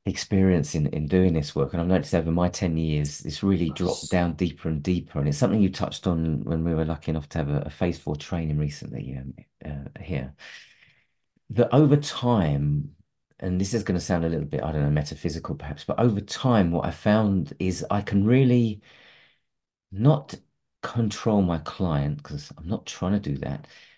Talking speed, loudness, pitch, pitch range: 200 wpm, -25 LUFS, 85 Hz, 75-100 Hz